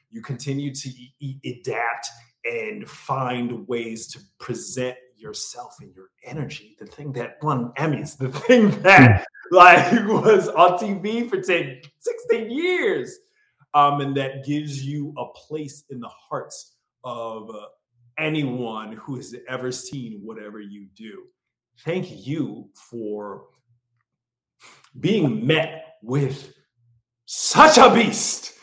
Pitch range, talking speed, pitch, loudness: 120-170 Hz, 125 wpm, 135 Hz, -19 LUFS